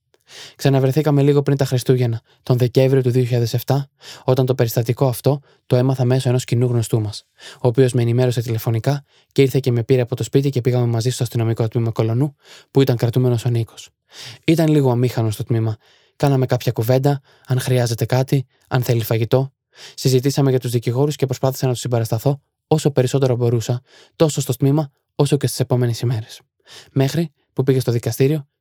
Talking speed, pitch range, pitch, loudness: 175 wpm, 120-135 Hz, 130 Hz, -19 LUFS